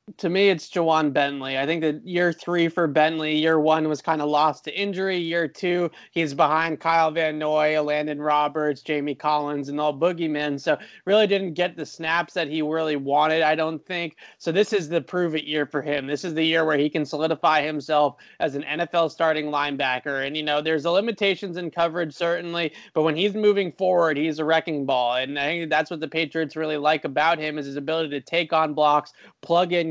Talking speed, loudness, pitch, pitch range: 215 wpm, -23 LUFS, 160 Hz, 150-170 Hz